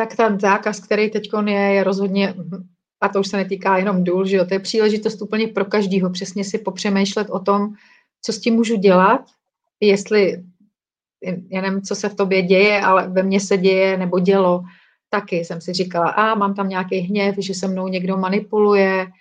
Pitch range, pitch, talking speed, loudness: 190-210 Hz, 195 Hz, 195 wpm, -18 LUFS